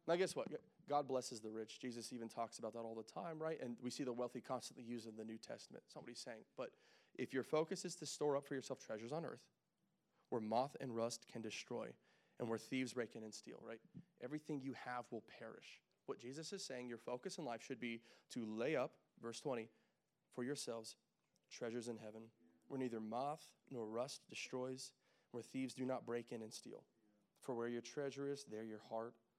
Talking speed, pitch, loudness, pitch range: 210 wpm, 125 Hz, -48 LUFS, 115-140 Hz